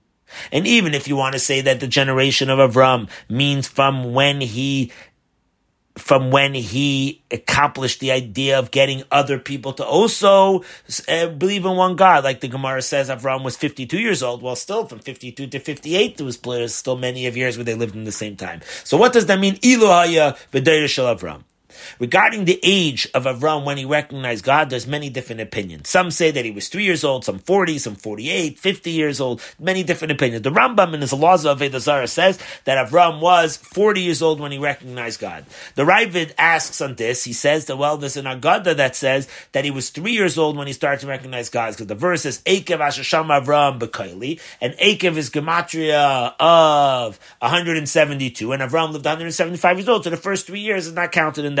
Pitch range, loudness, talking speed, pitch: 130-170 Hz, -18 LUFS, 195 wpm, 140 Hz